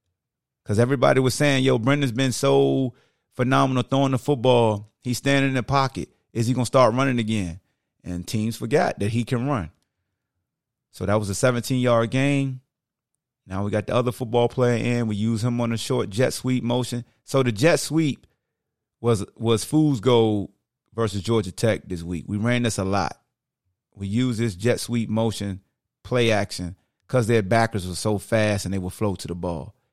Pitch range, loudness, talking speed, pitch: 105-130 Hz, -23 LUFS, 185 wpm, 120 Hz